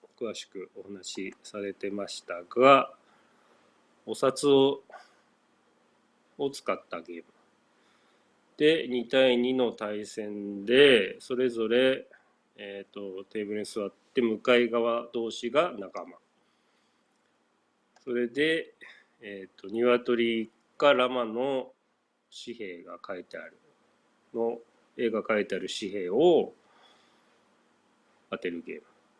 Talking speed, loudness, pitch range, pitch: 180 characters per minute, -27 LUFS, 105-130 Hz, 120 Hz